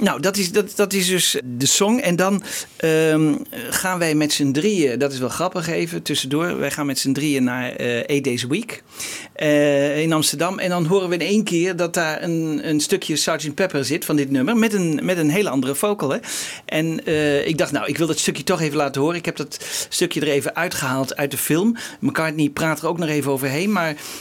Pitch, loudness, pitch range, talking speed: 155 Hz, -20 LUFS, 145-180 Hz, 230 wpm